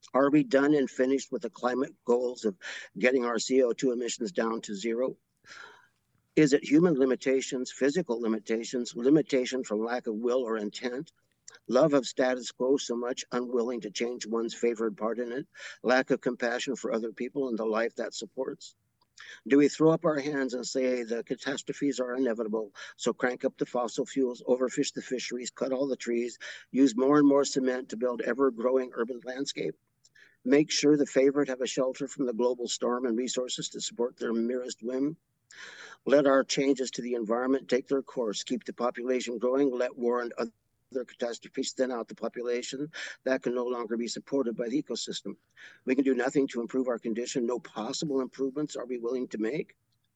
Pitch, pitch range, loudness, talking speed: 125 Hz, 120-135 Hz, -29 LUFS, 190 wpm